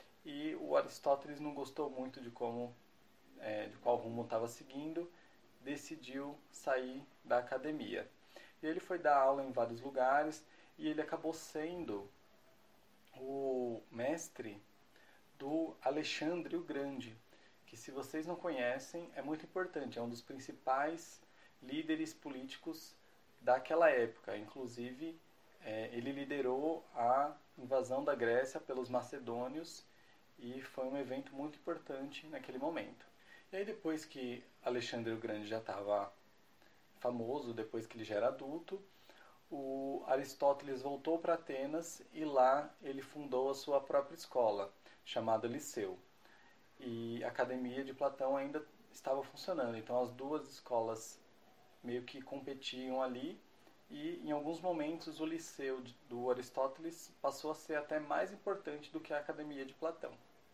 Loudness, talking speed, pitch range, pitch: -40 LUFS, 135 wpm, 125-155 Hz, 140 Hz